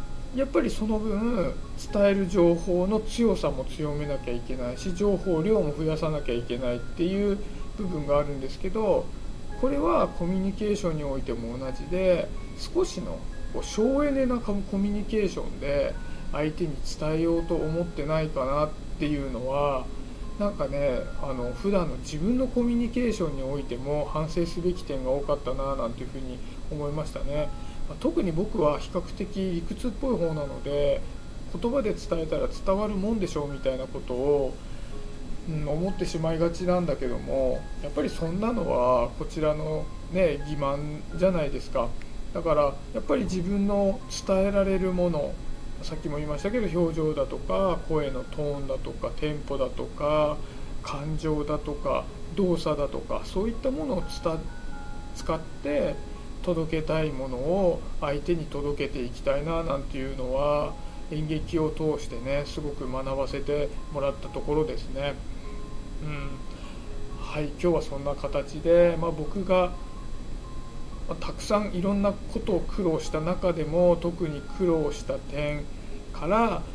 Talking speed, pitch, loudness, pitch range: 320 characters per minute, 155 Hz, -28 LUFS, 140-185 Hz